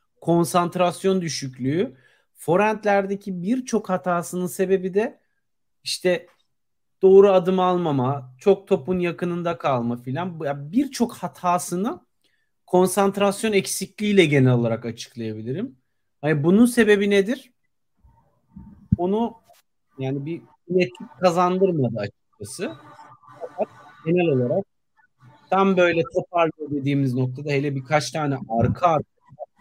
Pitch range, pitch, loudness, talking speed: 145-195 Hz, 175 Hz, -22 LUFS, 95 wpm